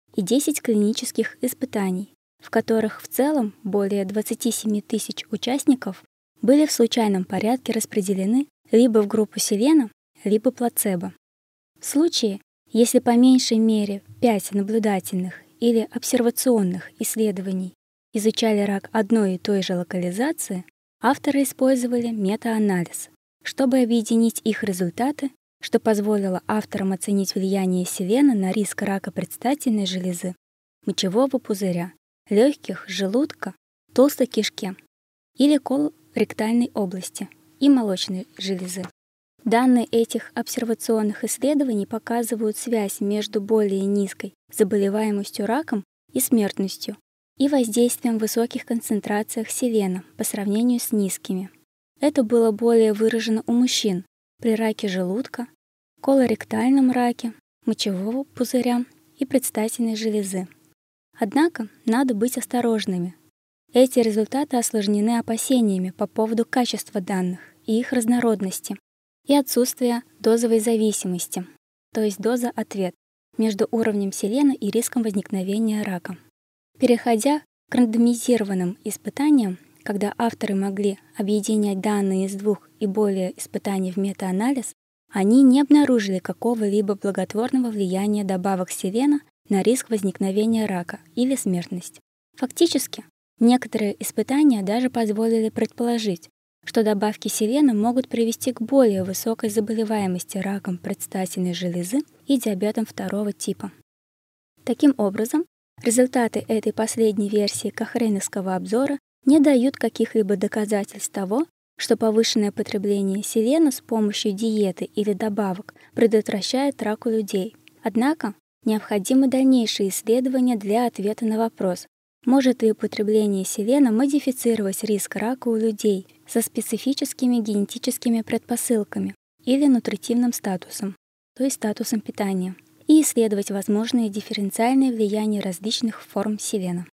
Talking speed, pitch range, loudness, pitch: 110 wpm, 200-240 Hz, -22 LUFS, 220 Hz